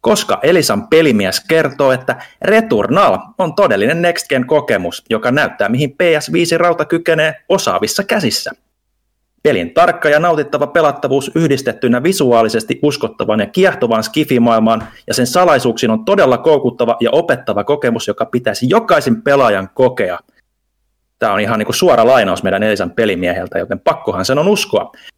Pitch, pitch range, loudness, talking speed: 145 Hz, 120-165 Hz, -13 LUFS, 135 wpm